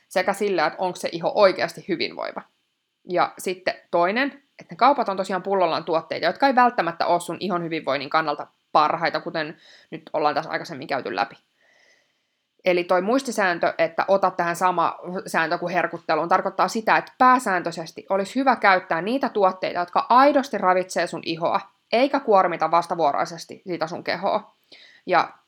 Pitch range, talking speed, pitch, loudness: 170-225 Hz, 155 wpm, 185 Hz, -22 LUFS